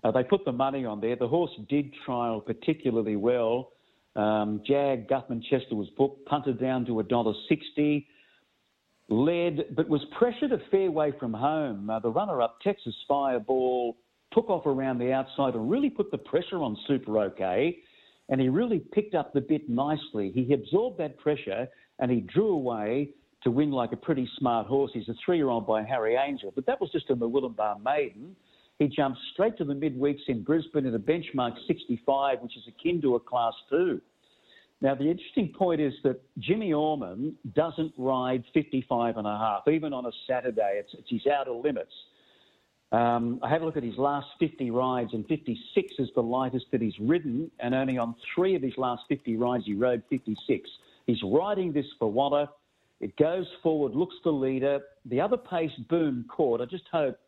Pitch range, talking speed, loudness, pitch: 120-155 Hz, 190 wpm, -28 LUFS, 135 Hz